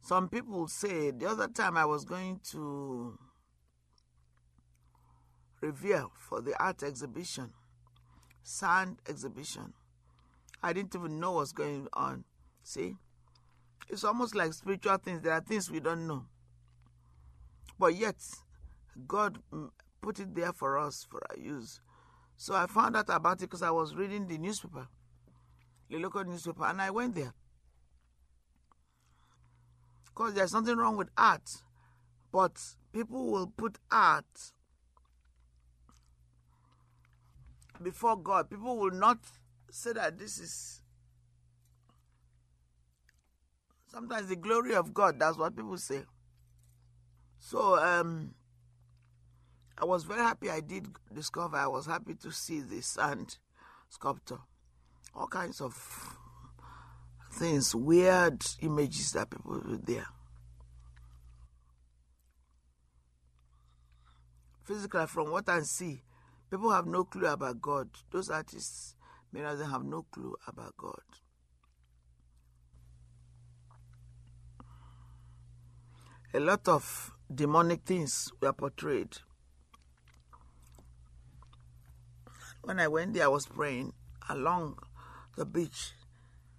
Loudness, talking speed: -33 LUFS, 110 wpm